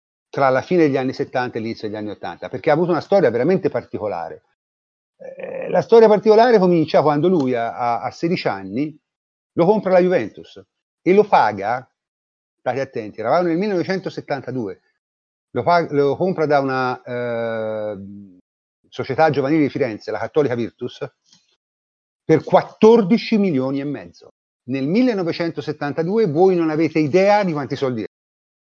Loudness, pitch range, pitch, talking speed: -18 LUFS, 120-180 Hz, 145 Hz, 145 wpm